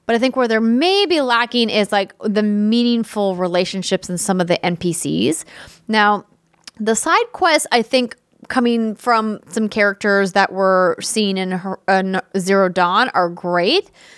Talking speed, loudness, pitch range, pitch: 155 wpm, -17 LUFS, 190-235 Hz, 210 Hz